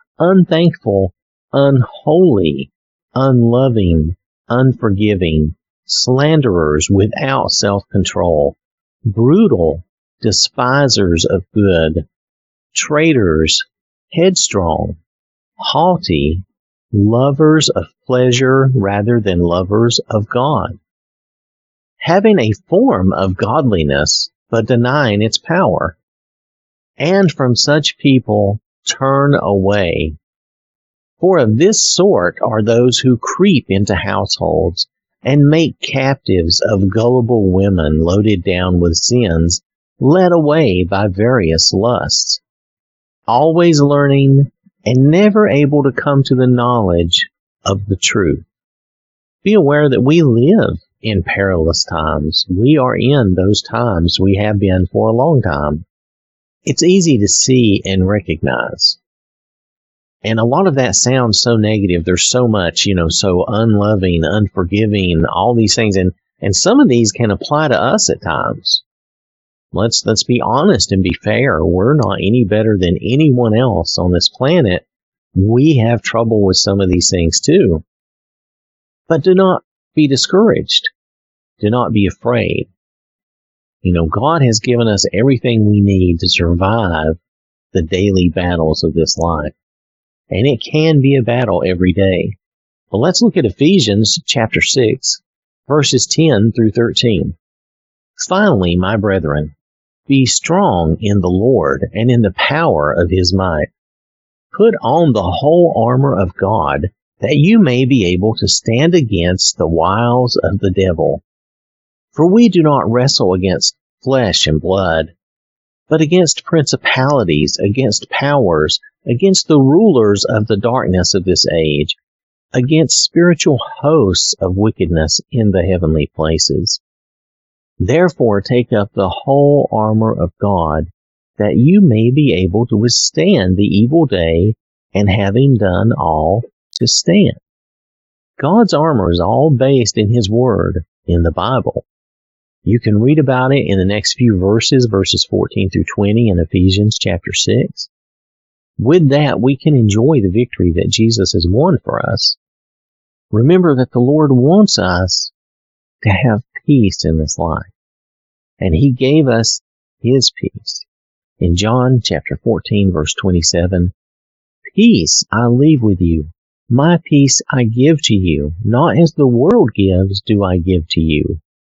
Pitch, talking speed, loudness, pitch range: 105 Hz, 135 wpm, -12 LUFS, 90-135 Hz